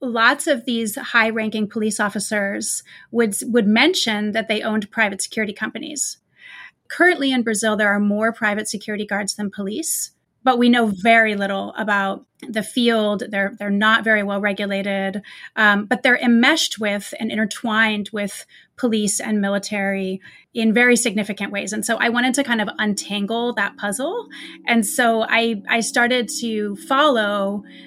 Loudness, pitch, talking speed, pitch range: -19 LUFS, 220 Hz, 155 wpm, 205-240 Hz